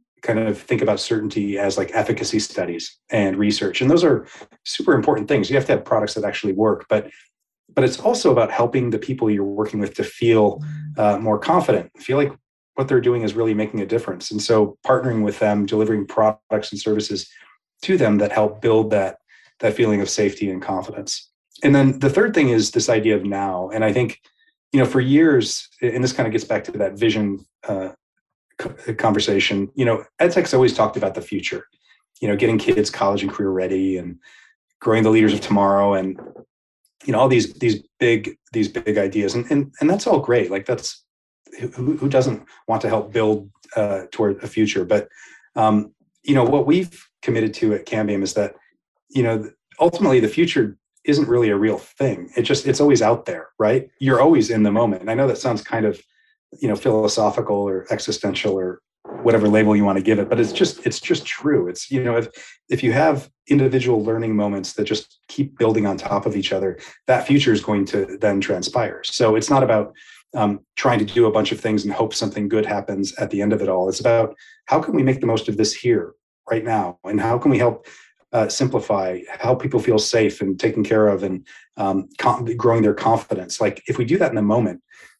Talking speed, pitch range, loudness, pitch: 215 wpm, 100-120 Hz, -19 LUFS, 110 Hz